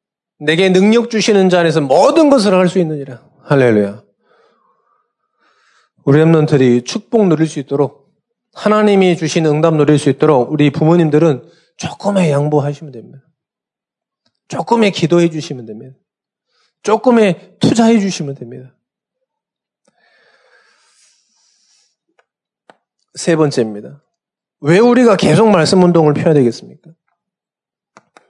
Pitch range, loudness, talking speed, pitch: 145-210 Hz, -12 LUFS, 250 characters per minute, 165 Hz